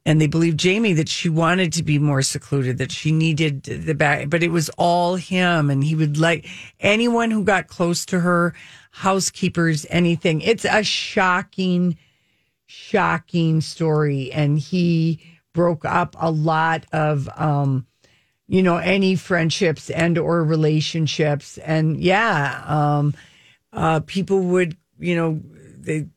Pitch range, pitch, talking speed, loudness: 150-175 Hz, 165 Hz, 140 wpm, -20 LUFS